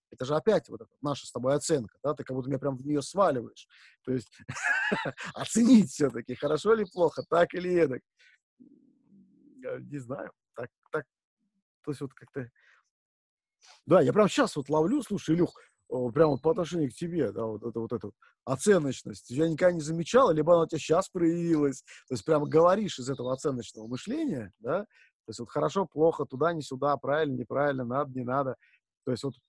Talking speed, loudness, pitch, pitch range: 185 wpm, -28 LUFS, 150 Hz, 130-180 Hz